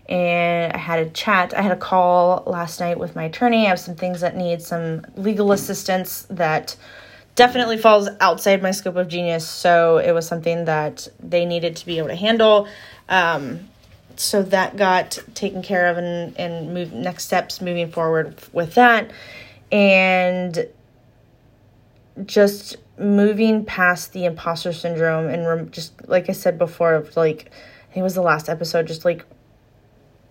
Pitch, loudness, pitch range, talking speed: 175 Hz, -19 LUFS, 165-190 Hz, 160 wpm